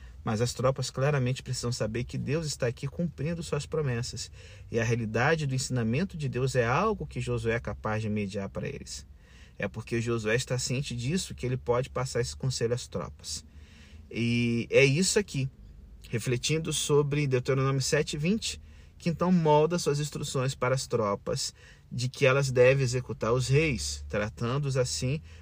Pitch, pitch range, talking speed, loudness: 125 Hz, 110-140 Hz, 165 wpm, -29 LUFS